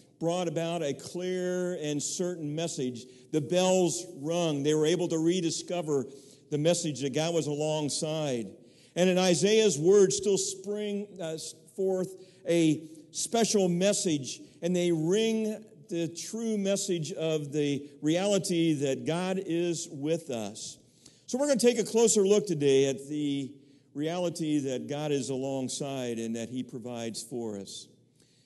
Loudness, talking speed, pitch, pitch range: -29 LUFS, 140 wpm, 165 Hz, 140-185 Hz